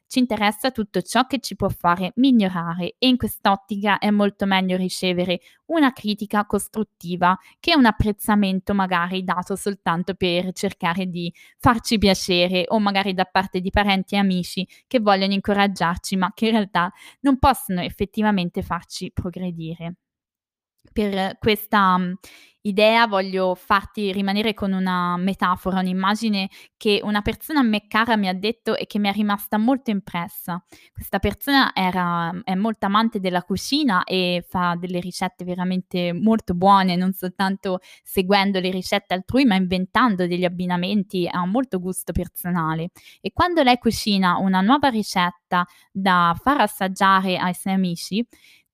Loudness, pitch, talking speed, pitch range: -21 LUFS, 195 Hz, 145 wpm, 180-210 Hz